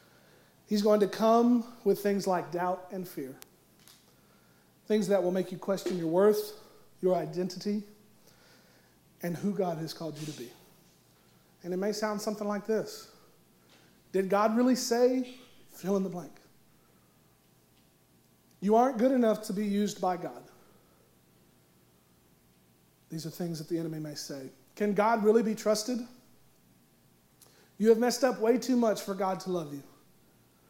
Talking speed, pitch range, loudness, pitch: 150 wpm, 155-215 Hz, -30 LUFS, 190 Hz